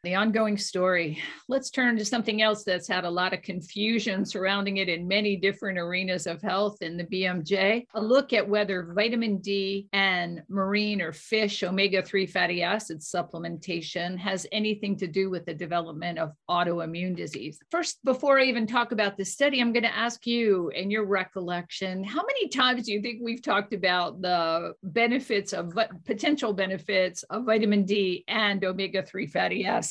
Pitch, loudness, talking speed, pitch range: 195 Hz, -27 LUFS, 175 wpm, 180-220 Hz